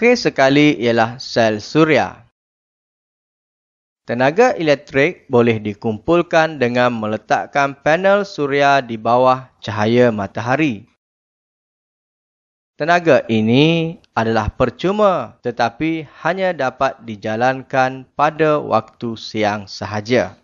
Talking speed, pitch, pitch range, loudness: 85 wpm, 130 Hz, 115-155 Hz, -17 LUFS